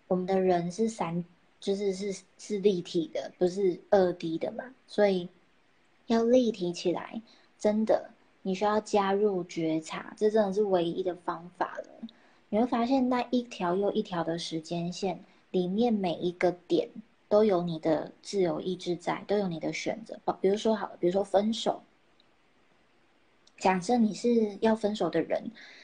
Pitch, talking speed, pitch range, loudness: 195 Hz, 230 characters per minute, 175-220 Hz, -29 LUFS